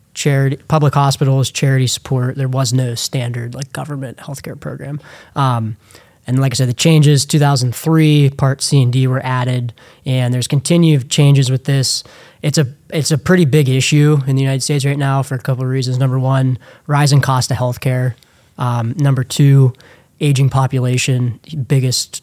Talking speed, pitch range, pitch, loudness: 175 wpm, 130-145 Hz, 135 Hz, -14 LUFS